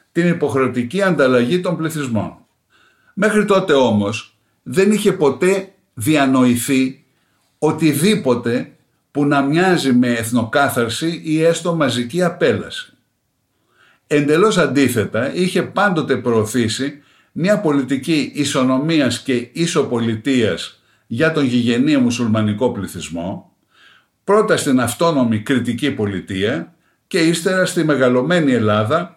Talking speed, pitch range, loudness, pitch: 95 wpm, 120-170 Hz, -17 LUFS, 140 Hz